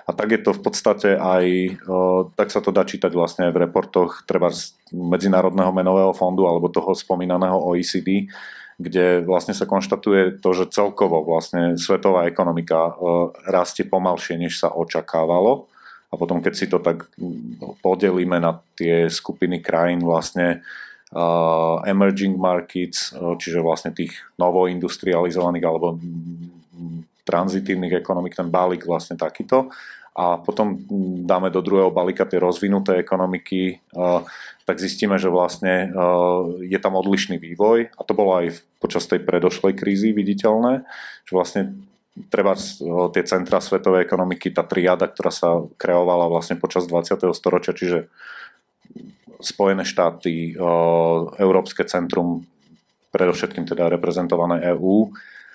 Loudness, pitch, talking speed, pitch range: -20 LUFS, 90 Hz, 130 wpm, 85-95 Hz